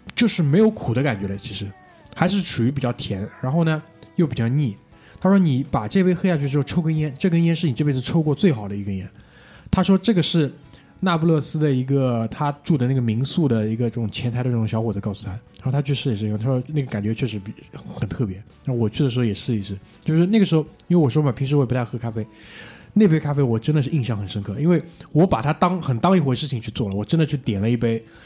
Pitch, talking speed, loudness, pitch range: 140 Hz, 370 characters per minute, -21 LUFS, 115-160 Hz